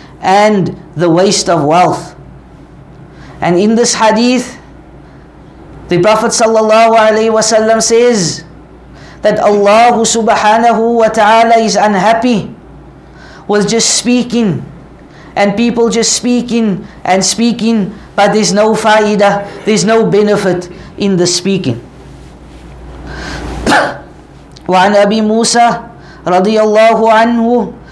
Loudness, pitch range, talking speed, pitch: -9 LUFS, 180-225 Hz, 90 wpm, 210 Hz